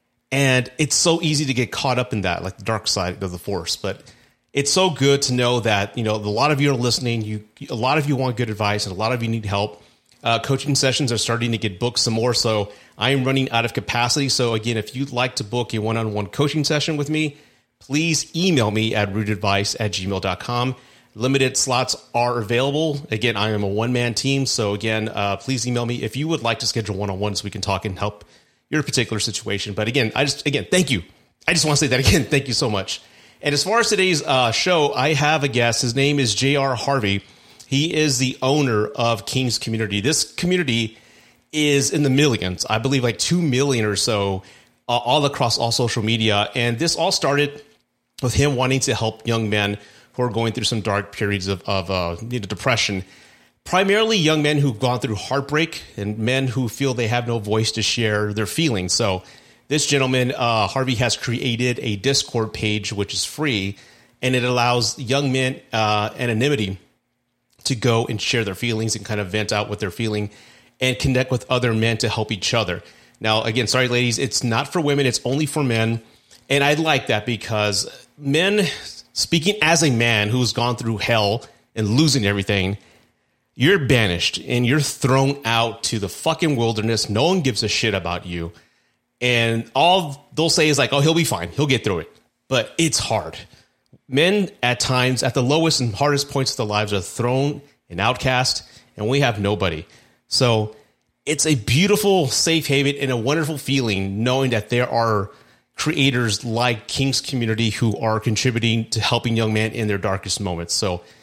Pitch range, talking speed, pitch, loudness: 105-140 Hz, 200 wpm, 120 Hz, -20 LUFS